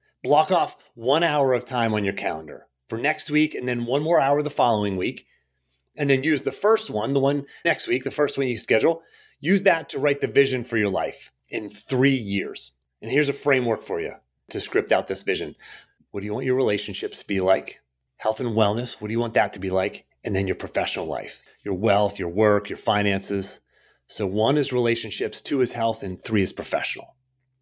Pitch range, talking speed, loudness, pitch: 100-135 Hz, 215 wpm, -24 LUFS, 115 Hz